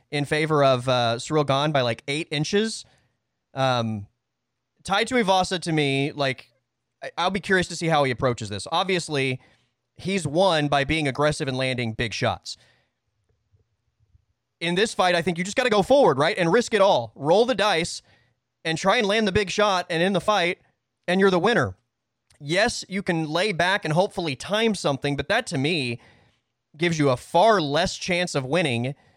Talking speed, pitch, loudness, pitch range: 190 wpm, 150 Hz, -23 LUFS, 120-180 Hz